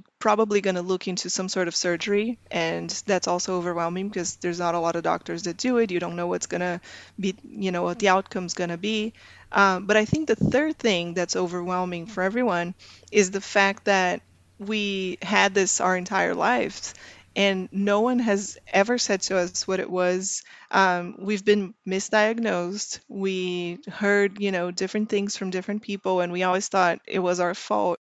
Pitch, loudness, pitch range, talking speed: 190 Hz, -24 LUFS, 180-205 Hz, 195 wpm